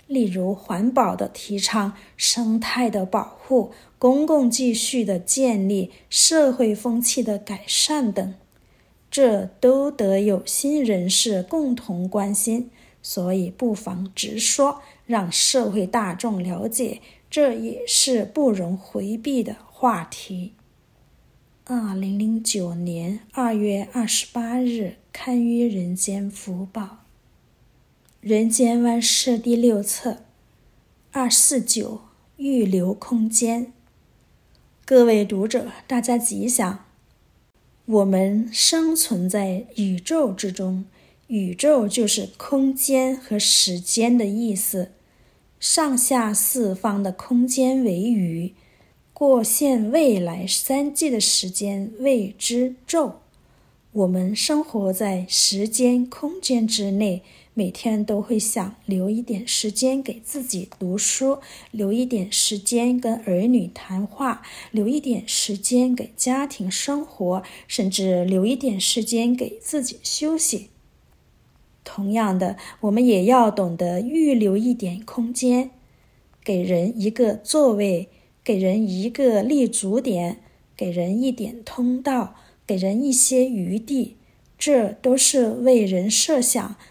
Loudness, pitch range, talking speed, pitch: -21 LUFS, 200-250 Hz, 170 characters per minute, 225 Hz